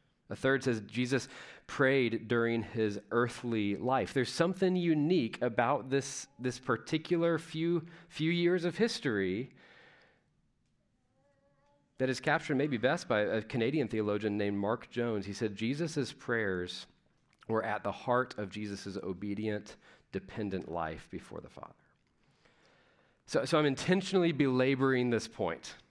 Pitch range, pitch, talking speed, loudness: 110-145 Hz, 125 Hz, 130 wpm, -33 LUFS